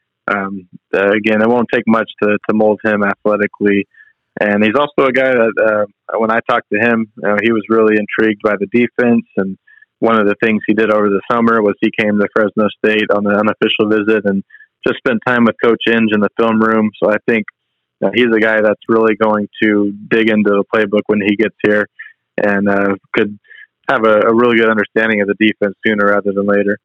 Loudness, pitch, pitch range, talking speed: -14 LUFS, 105 Hz, 100-110 Hz, 220 wpm